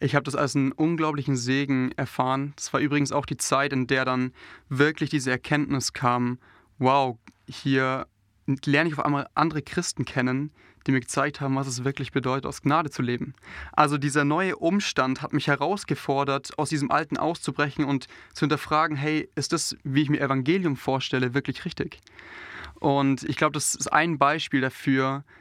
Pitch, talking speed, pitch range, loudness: 140 Hz, 175 wpm, 130-150 Hz, -25 LUFS